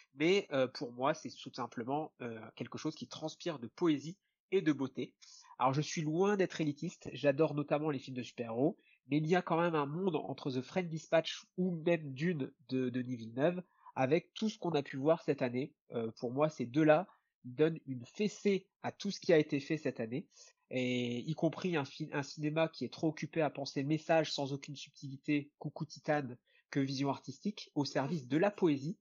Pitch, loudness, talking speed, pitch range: 150 Hz, -36 LUFS, 195 wpm, 135-165 Hz